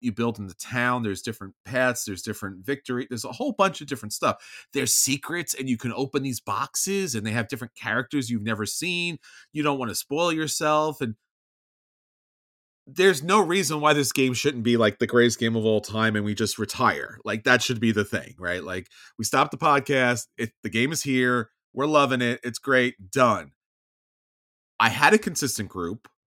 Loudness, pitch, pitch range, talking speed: -24 LUFS, 125 Hz, 110-140 Hz, 200 wpm